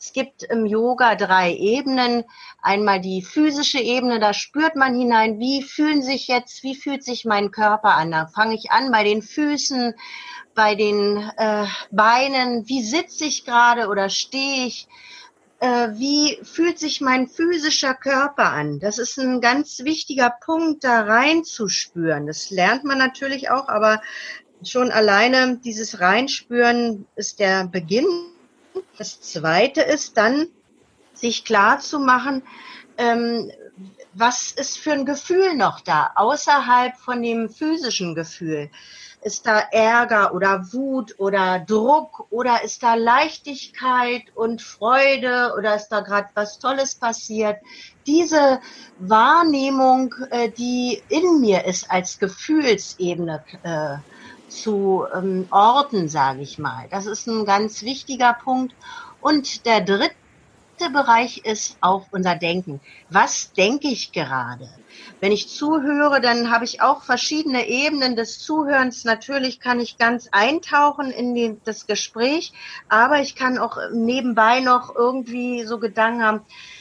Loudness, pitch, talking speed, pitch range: -19 LUFS, 240 Hz, 135 wpm, 210-275 Hz